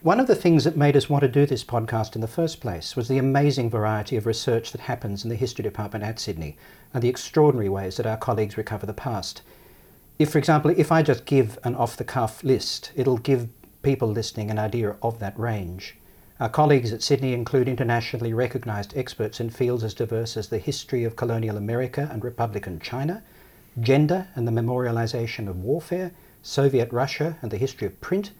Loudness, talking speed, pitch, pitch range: -24 LUFS, 200 wpm, 120 Hz, 110-140 Hz